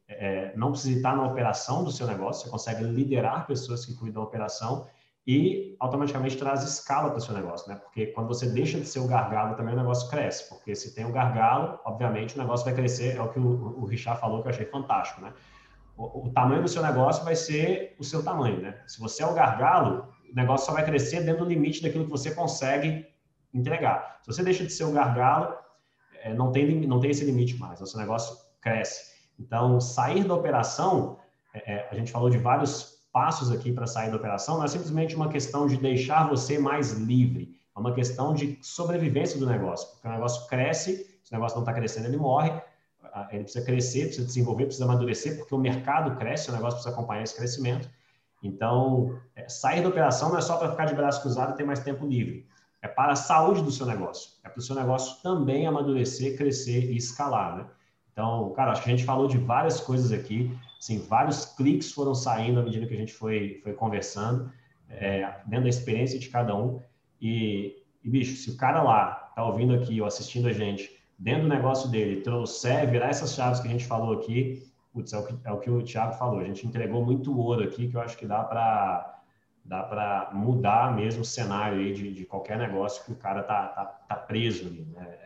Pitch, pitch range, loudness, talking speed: 125 Hz, 115-140 Hz, -28 LUFS, 215 wpm